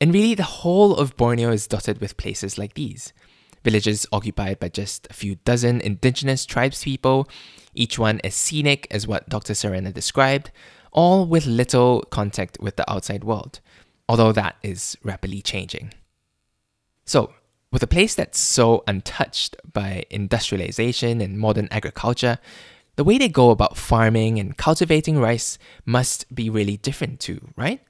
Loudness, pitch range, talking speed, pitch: -21 LUFS, 105-130 Hz, 150 wpm, 115 Hz